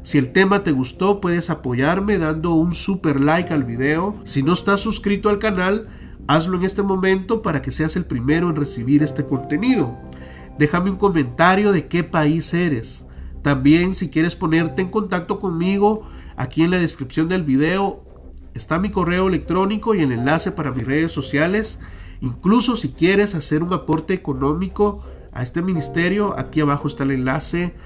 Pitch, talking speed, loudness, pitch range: 165 Hz, 170 wpm, -19 LUFS, 145-190 Hz